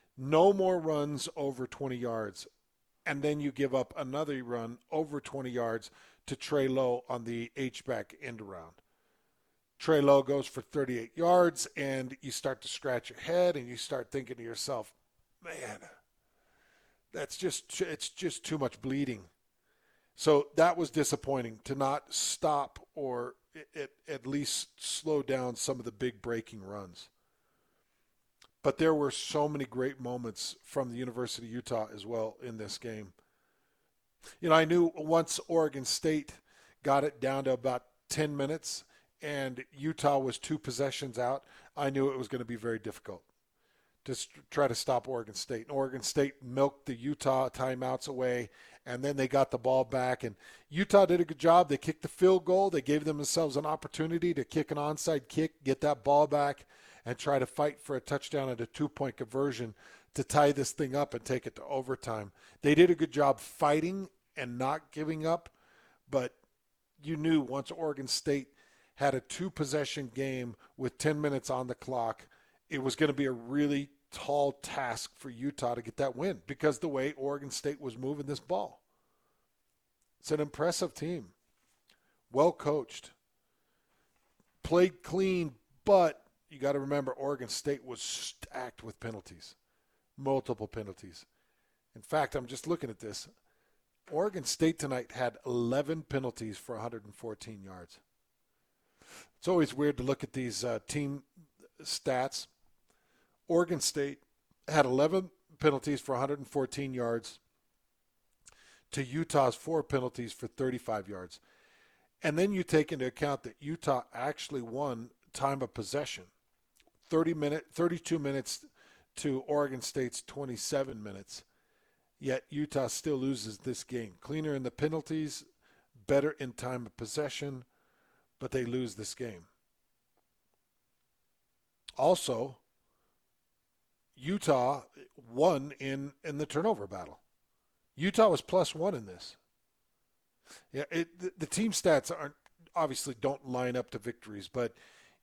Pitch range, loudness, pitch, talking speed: 125-150 Hz, -33 LUFS, 140 Hz, 150 wpm